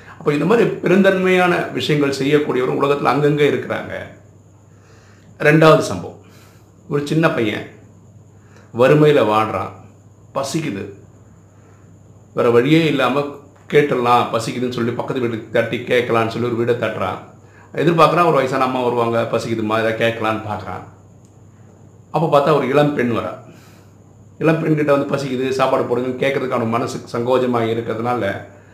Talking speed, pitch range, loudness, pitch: 115 wpm, 105-140 Hz, -17 LUFS, 115 Hz